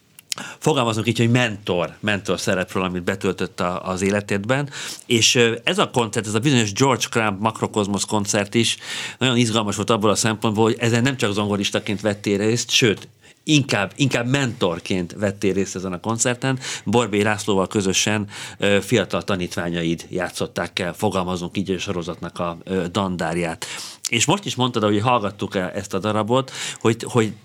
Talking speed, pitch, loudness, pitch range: 150 wpm, 105 Hz, -21 LUFS, 95-120 Hz